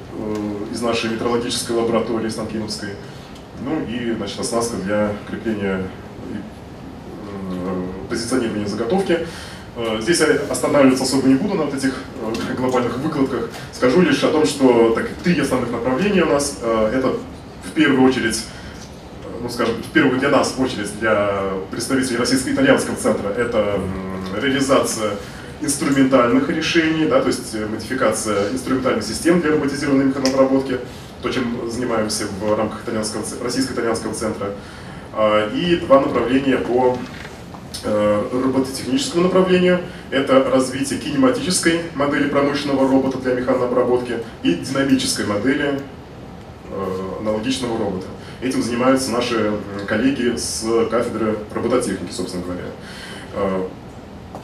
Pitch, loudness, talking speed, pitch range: 120 Hz, -19 LUFS, 110 wpm, 105-135 Hz